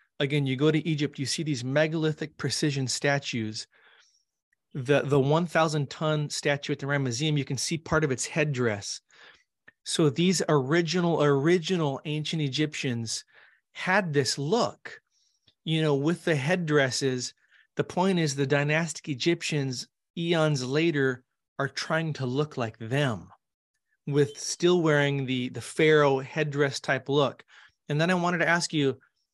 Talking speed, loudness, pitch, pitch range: 145 wpm, -27 LUFS, 145 Hz, 140-160 Hz